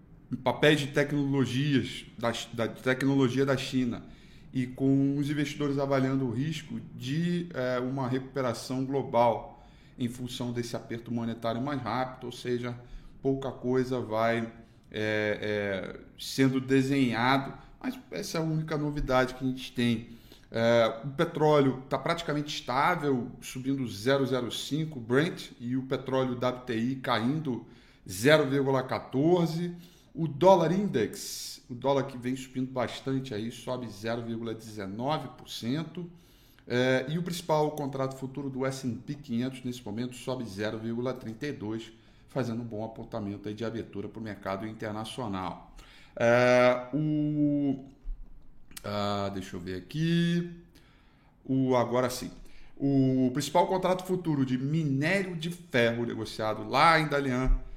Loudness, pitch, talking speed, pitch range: -30 LUFS, 130 Hz, 125 wpm, 120-145 Hz